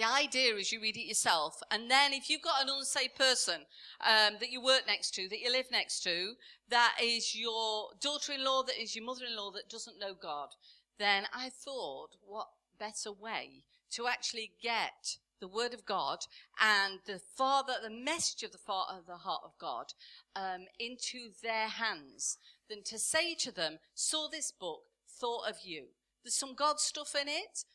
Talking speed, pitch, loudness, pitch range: 180 wpm, 235 Hz, -33 LUFS, 215-270 Hz